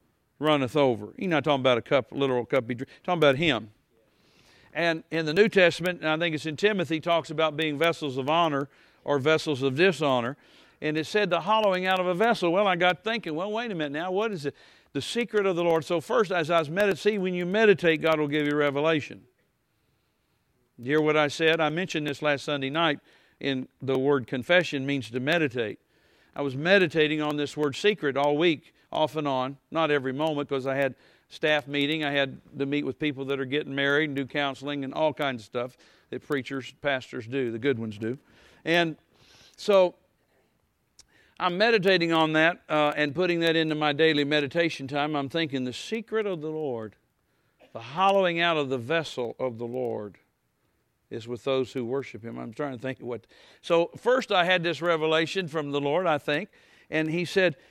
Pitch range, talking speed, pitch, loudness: 140-170 Hz, 205 wpm, 150 Hz, -26 LUFS